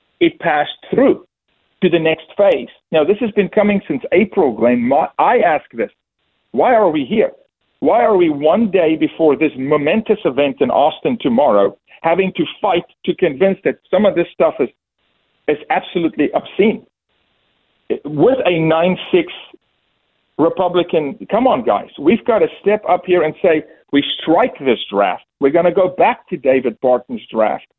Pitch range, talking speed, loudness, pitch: 155-205 Hz, 170 wpm, -15 LUFS, 175 Hz